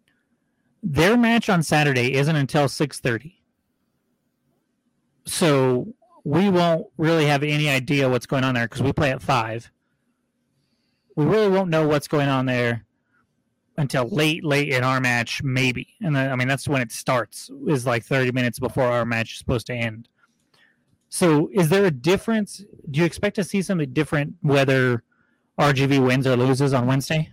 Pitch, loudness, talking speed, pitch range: 140 Hz, -21 LUFS, 165 wpm, 130-160 Hz